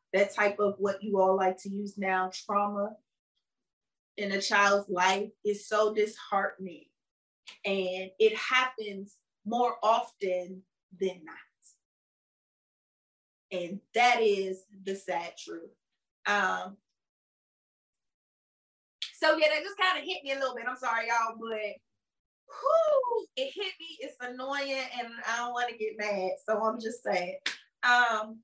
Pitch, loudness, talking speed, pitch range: 210 Hz, -29 LUFS, 135 wpm, 195-245 Hz